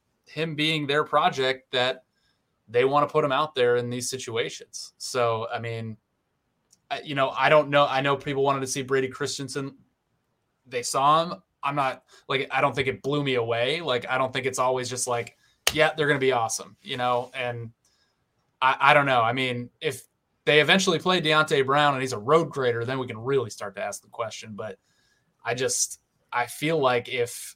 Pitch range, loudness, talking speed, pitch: 125-150 Hz, -24 LUFS, 205 wpm, 135 Hz